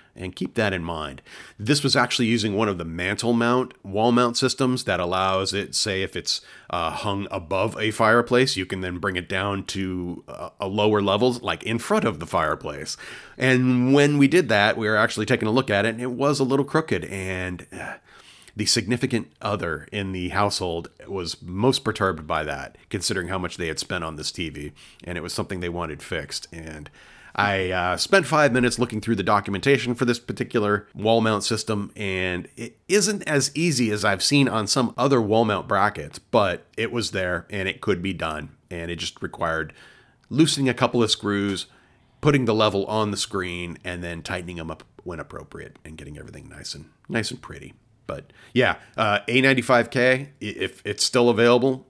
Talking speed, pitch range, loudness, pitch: 195 wpm, 90-125 Hz, -23 LUFS, 105 Hz